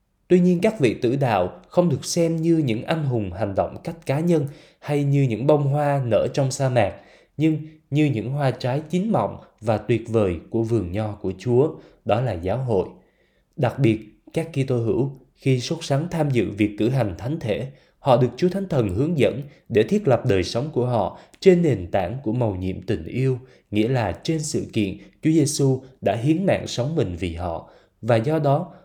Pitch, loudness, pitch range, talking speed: 130 Hz, -22 LUFS, 110-155 Hz, 210 wpm